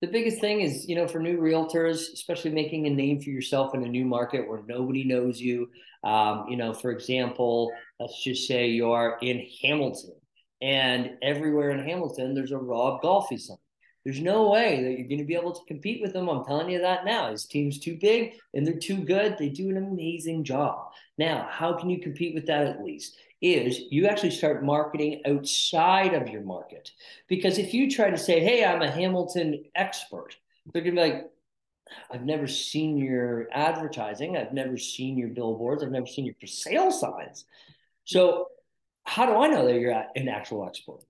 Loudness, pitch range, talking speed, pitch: -27 LUFS, 125-170 Hz, 195 wpm, 145 Hz